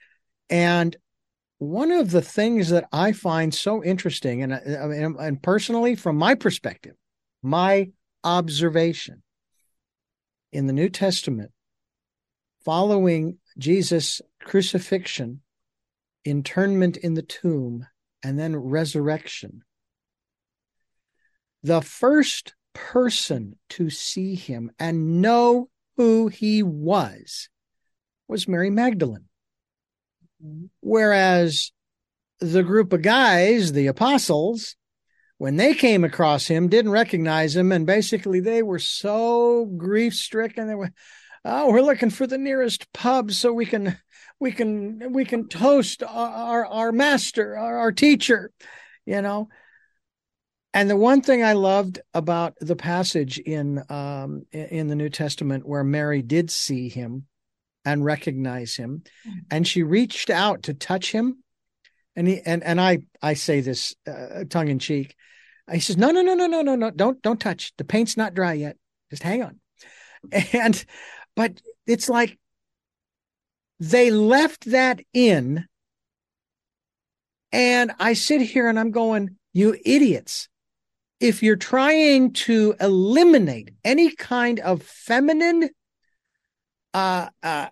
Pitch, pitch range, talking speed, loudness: 195 Hz, 160-235 Hz, 125 wpm, -21 LUFS